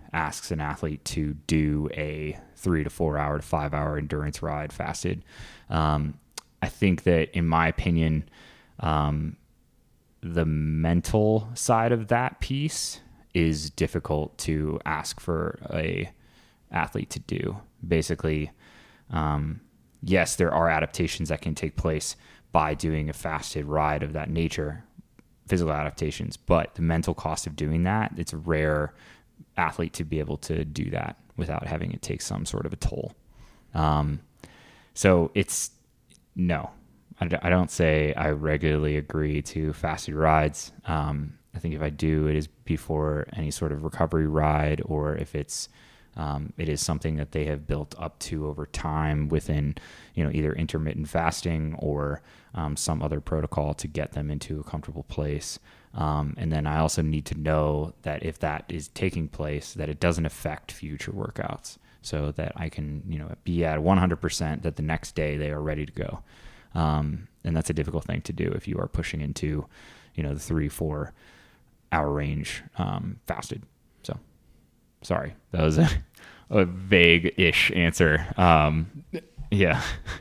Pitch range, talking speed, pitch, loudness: 75-85 Hz, 160 wpm, 75 Hz, -27 LUFS